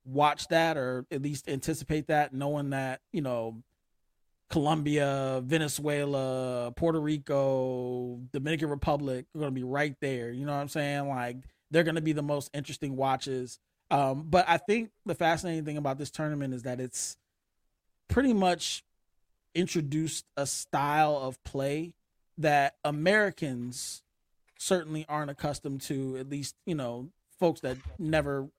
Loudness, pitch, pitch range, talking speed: -30 LUFS, 145 Hz, 135-155 Hz, 145 wpm